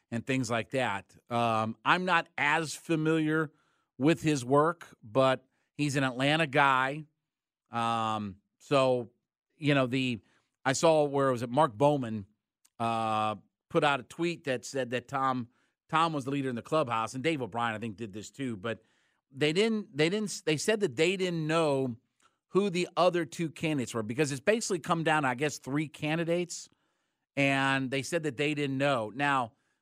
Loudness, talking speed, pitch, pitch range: -30 LUFS, 175 wpm, 140 Hz, 120-160 Hz